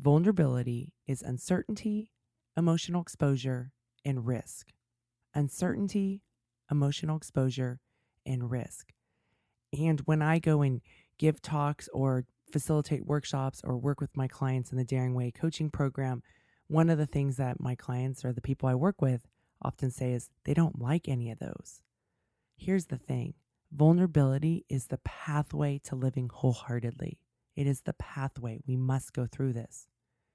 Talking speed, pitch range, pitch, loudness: 145 wpm, 125-155 Hz, 135 Hz, -32 LUFS